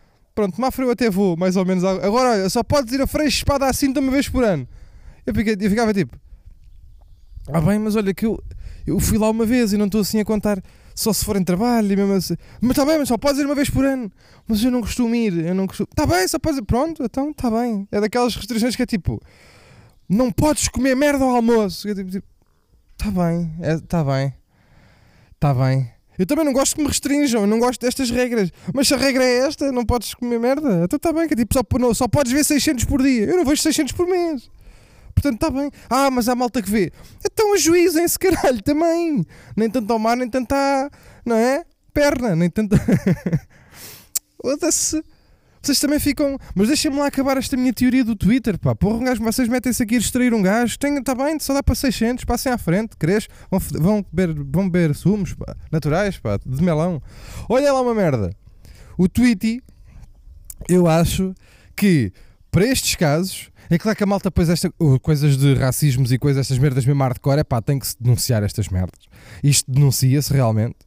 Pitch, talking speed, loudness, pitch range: 220 Hz, 215 wpm, -19 LUFS, 160-265 Hz